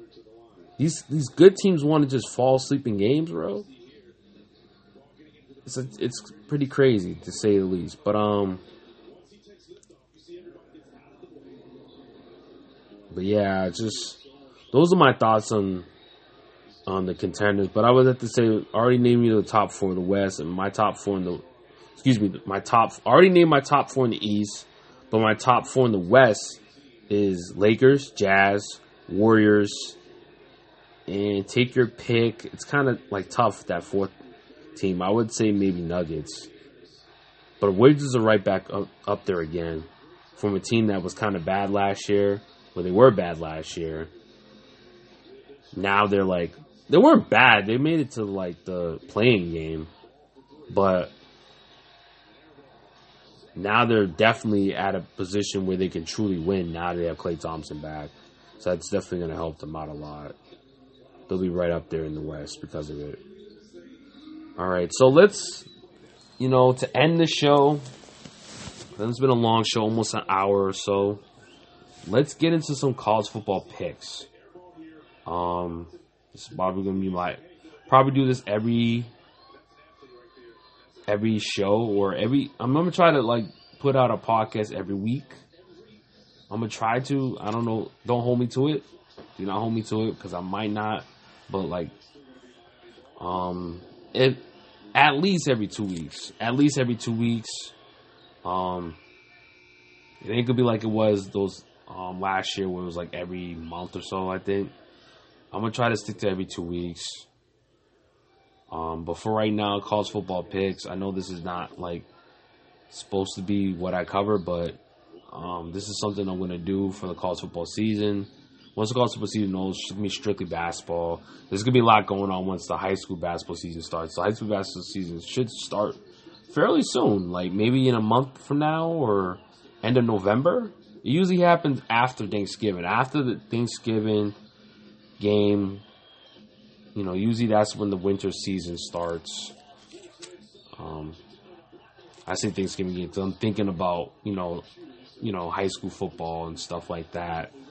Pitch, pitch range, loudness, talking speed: 105 Hz, 90-120 Hz, -24 LUFS, 165 wpm